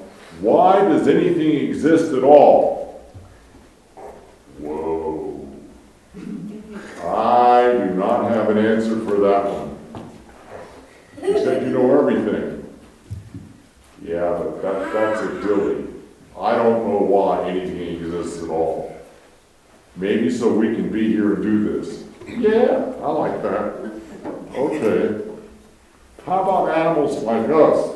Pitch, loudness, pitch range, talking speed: 110 Hz, -18 LUFS, 95-145 Hz, 115 wpm